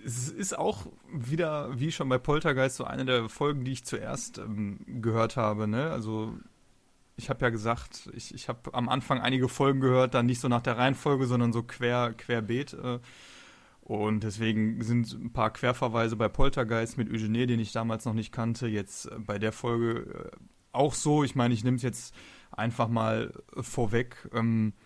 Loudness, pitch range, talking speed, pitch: -30 LUFS, 115-130 Hz, 185 wpm, 120 Hz